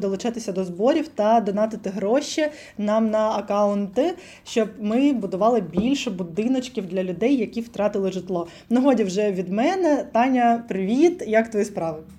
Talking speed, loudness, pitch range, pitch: 145 wpm, -22 LUFS, 200-245 Hz, 220 Hz